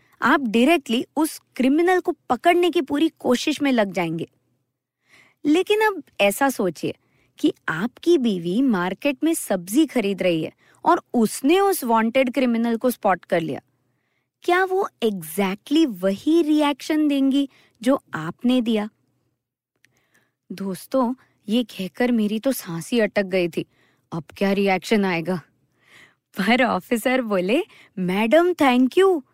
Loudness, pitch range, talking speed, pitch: -21 LUFS, 200-305 Hz, 125 wpm, 250 Hz